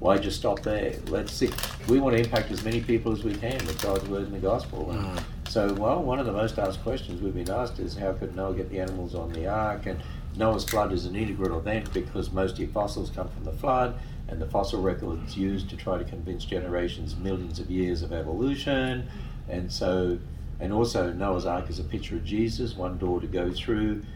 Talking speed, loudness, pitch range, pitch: 225 wpm, -29 LUFS, 90-110 Hz, 95 Hz